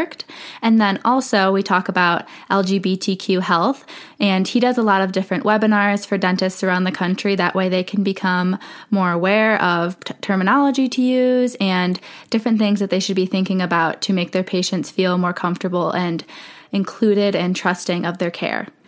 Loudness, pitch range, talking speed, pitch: -18 LUFS, 180-210 Hz, 180 wpm, 190 Hz